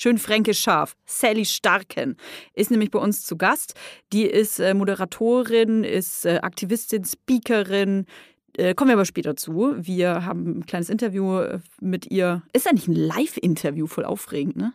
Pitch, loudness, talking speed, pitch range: 205 Hz, -22 LUFS, 150 wpm, 185-230 Hz